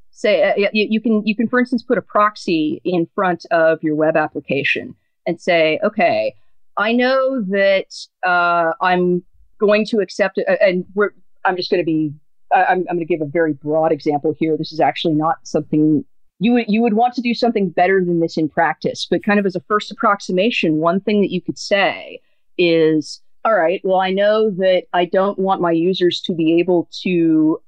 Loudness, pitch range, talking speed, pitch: -17 LUFS, 165-210 Hz, 200 wpm, 185 Hz